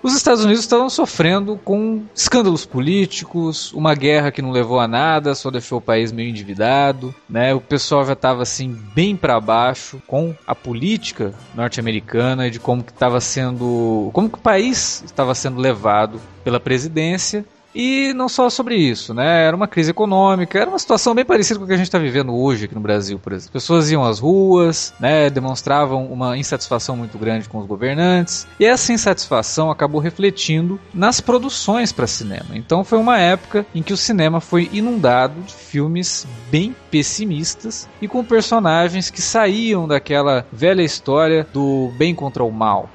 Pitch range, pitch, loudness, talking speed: 125-195 Hz, 155 Hz, -17 LUFS, 175 wpm